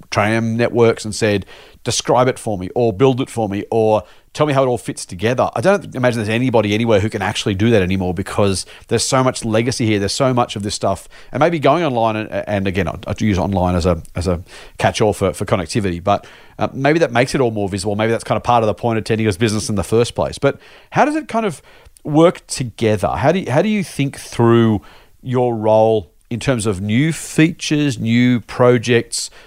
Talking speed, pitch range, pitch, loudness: 230 wpm, 105-130 Hz, 115 Hz, -17 LUFS